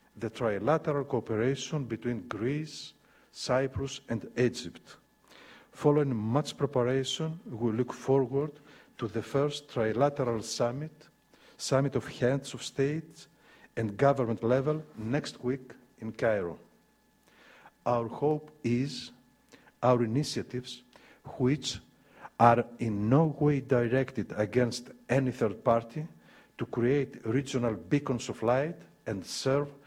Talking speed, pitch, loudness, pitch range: 110 wpm, 130 Hz, -30 LUFS, 120-145 Hz